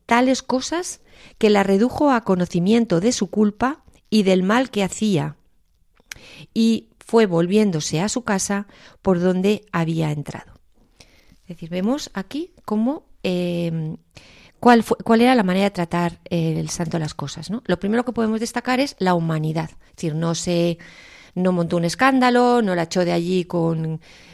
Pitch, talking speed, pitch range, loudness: 190 Hz, 165 wpm, 170-230 Hz, -20 LUFS